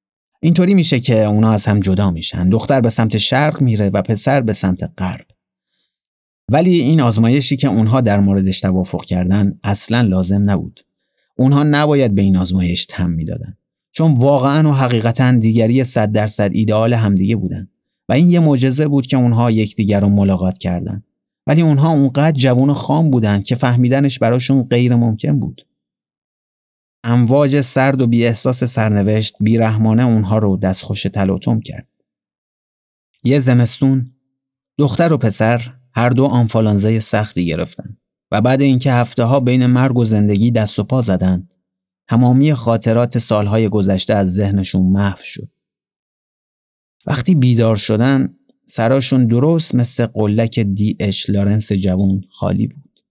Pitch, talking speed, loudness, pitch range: 115 Hz, 145 wpm, -14 LUFS, 100-135 Hz